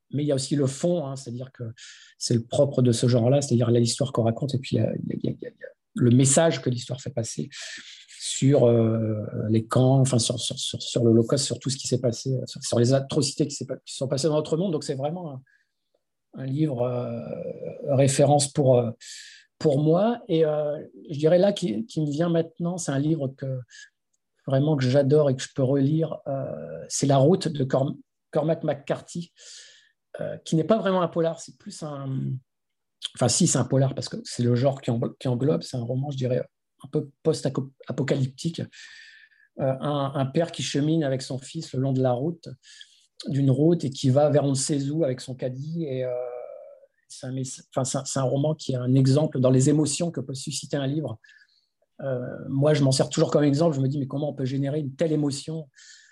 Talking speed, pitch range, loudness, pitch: 210 wpm, 130-160 Hz, -24 LUFS, 140 Hz